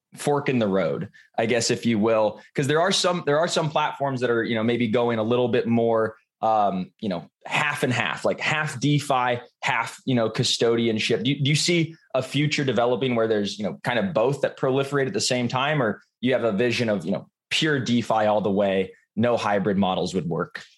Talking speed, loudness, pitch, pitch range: 225 wpm, -23 LUFS, 120 Hz, 110-140 Hz